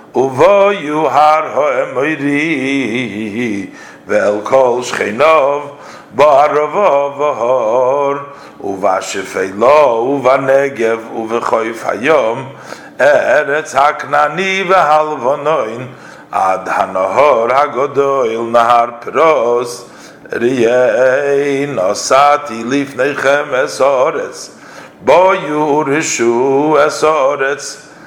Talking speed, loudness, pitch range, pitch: 85 wpm, -12 LUFS, 120-150 Hz, 140 Hz